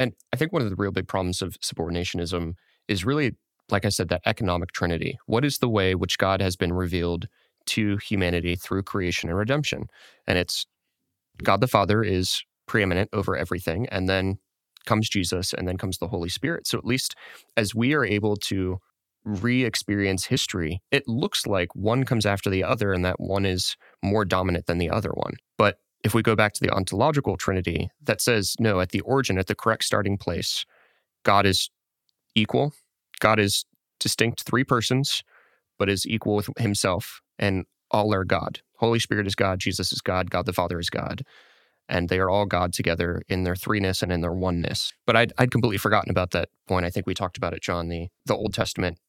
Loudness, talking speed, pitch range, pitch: -25 LUFS, 200 wpm, 90-110 Hz, 100 Hz